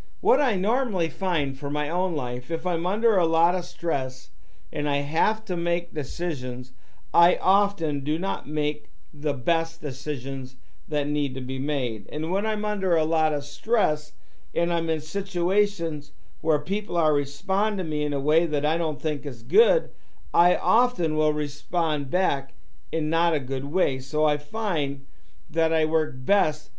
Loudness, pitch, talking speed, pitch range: -25 LUFS, 160 Hz, 175 wpm, 145-180 Hz